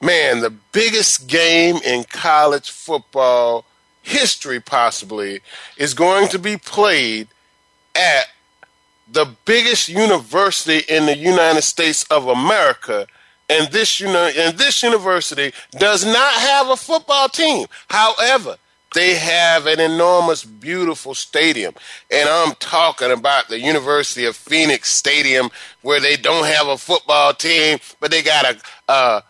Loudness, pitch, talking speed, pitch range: -15 LUFS, 165 Hz, 135 wpm, 145-200 Hz